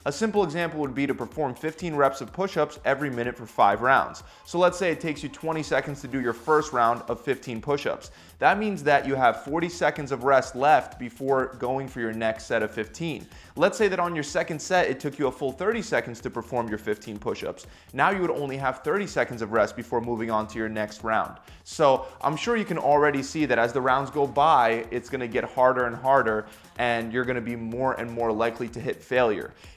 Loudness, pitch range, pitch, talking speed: -25 LUFS, 115-150 Hz, 135 Hz, 235 wpm